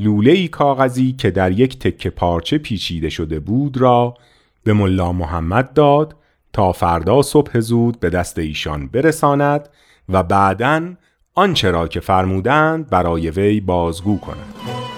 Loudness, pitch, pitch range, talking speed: -16 LUFS, 105 Hz, 90-140 Hz, 130 wpm